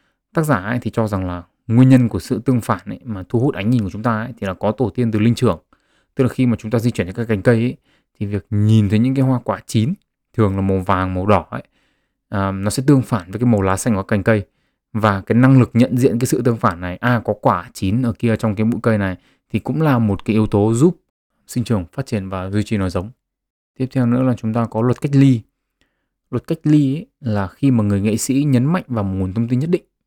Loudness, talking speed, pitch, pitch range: -18 LUFS, 285 wpm, 115 Hz, 105-125 Hz